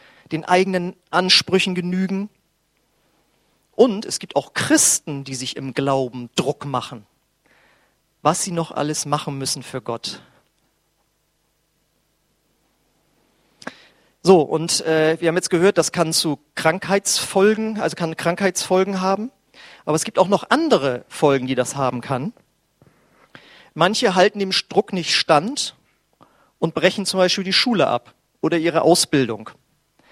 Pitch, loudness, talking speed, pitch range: 170 Hz, -19 LUFS, 130 wpm, 145-190 Hz